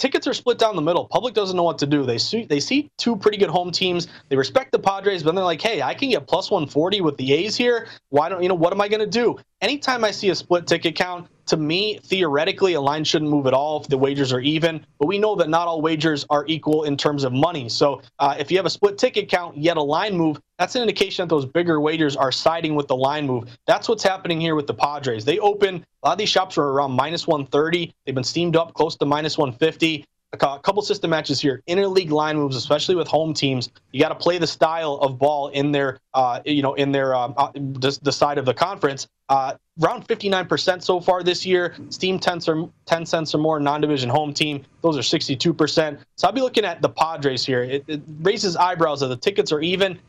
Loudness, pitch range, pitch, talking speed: -21 LUFS, 145-185 Hz, 160 Hz, 255 wpm